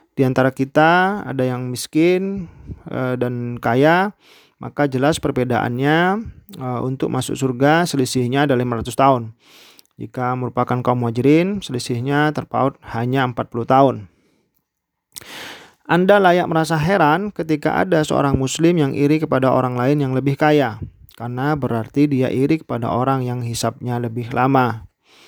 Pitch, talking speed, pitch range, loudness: 130 Hz, 125 wpm, 125-155 Hz, -18 LUFS